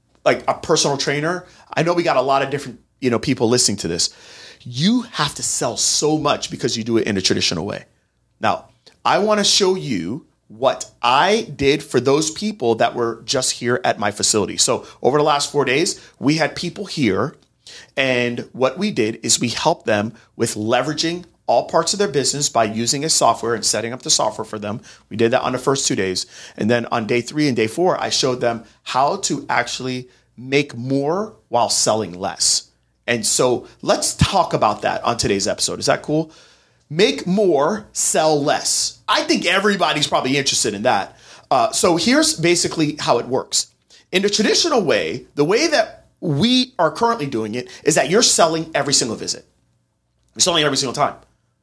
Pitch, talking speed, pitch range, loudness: 140 Hz, 195 wpm, 120-175 Hz, -18 LUFS